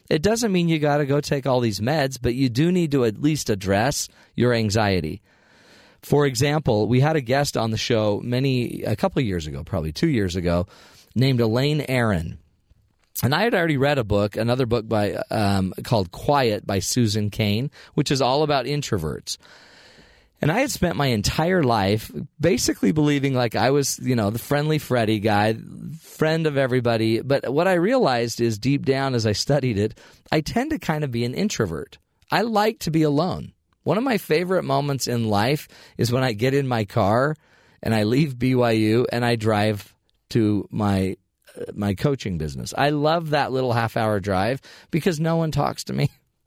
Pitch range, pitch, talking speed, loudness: 110-150 Hz, 125 Hz, 190 wpm, -22 LUFS